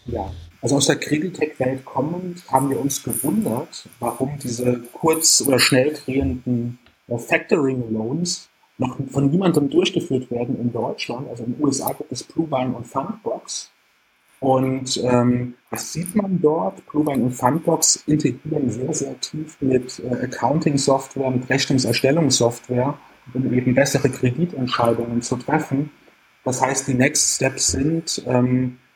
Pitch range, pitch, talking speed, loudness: 125-150 Hz, 130 Hz, 135 wpm, -21 LUFS